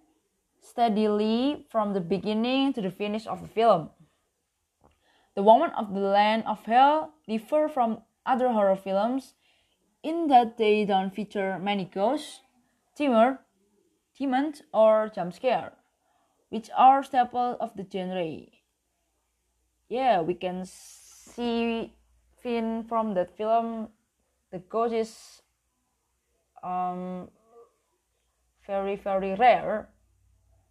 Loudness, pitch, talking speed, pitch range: -26 LUFS, 220 Hz, 100 wpm, 195-240 Hz